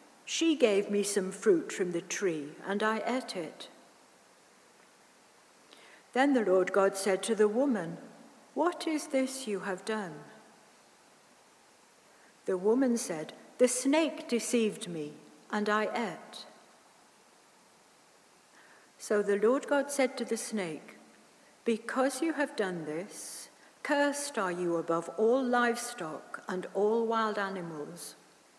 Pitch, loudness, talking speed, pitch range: 220 Hz, -31 LUFS, 125 wpm, 190-260 Hz